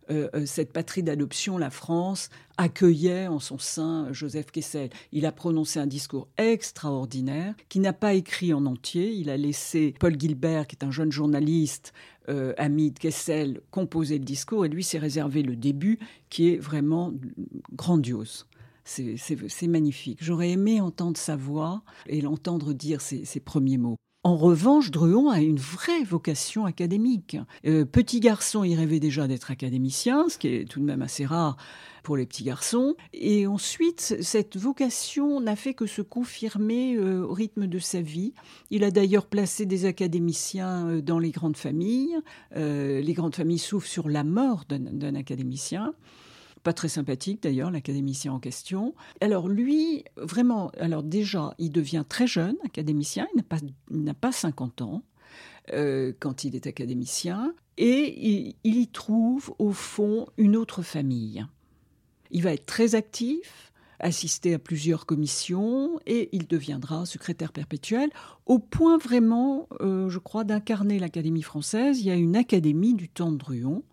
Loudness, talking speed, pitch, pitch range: -26 LUFS, 165 wpm, 170 Hz, 150-210 Hz